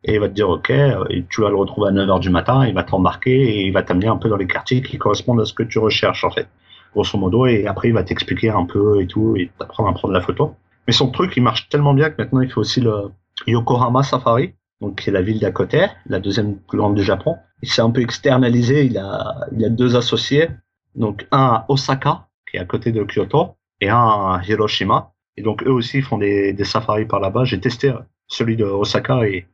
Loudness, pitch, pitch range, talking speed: -18 LUFS, 110 Hz, 100-130 Hz, 250 wpm